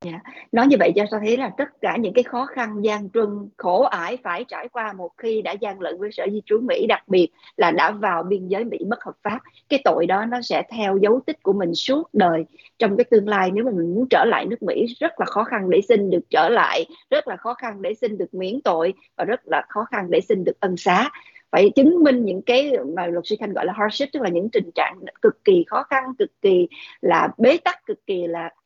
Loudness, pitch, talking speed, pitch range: -21 LUFS, 230 Hz, 260 wpm, 195-280 Hz